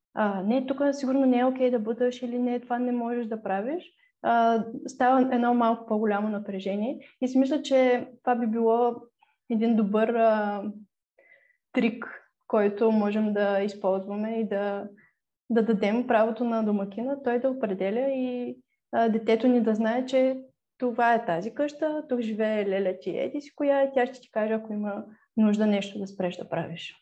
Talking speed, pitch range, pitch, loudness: 170 wpm, 210-255 Hz, 230 Hz, -26 LUFS